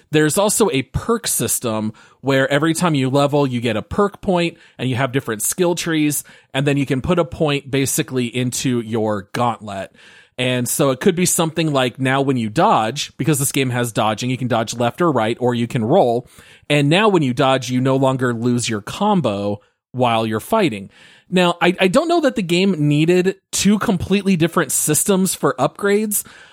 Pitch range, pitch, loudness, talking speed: 125-175 Hz, 140 Hz, -18 LUFS, 195 wpm